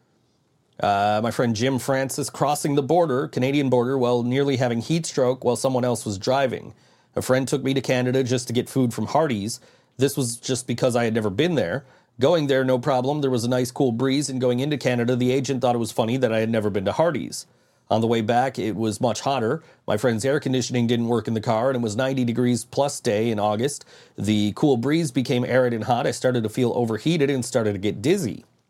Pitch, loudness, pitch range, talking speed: 125 Hz, -23 LUFS, 115-135 Hz, 230 wpm